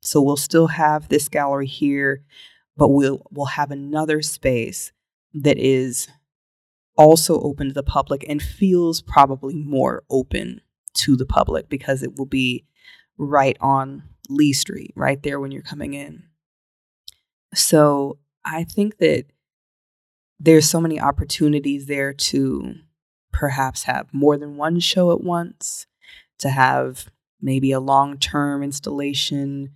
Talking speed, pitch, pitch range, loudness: 135 wpm, 145 Hz, 135-155 Hz, -19 LUFS